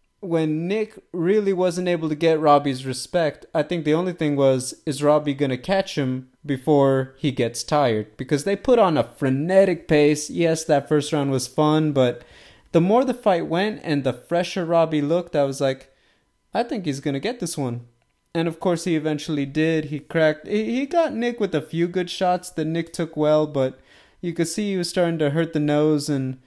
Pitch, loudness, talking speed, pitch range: 155 Hz, -22 LUFS, 210 wpm, 145-175 Hz